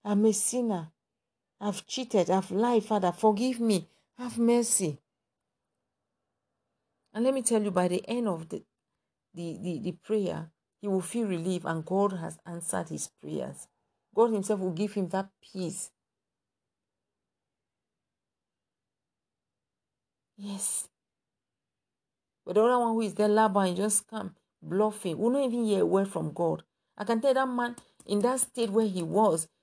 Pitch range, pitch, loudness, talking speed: 180-225 Hz, 205 Hz, -29 LUFS, 150 wpm